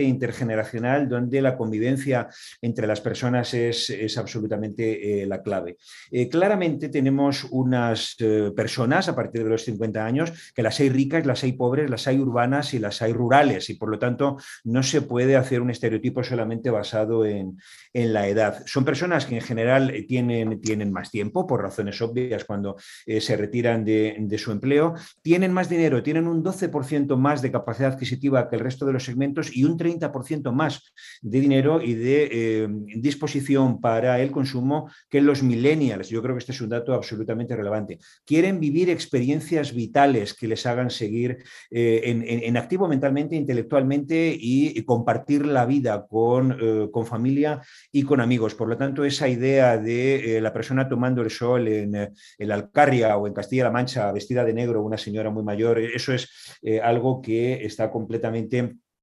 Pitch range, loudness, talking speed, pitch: 115-140 Hz, -23 LUFS, 180 wpm, 125 Hz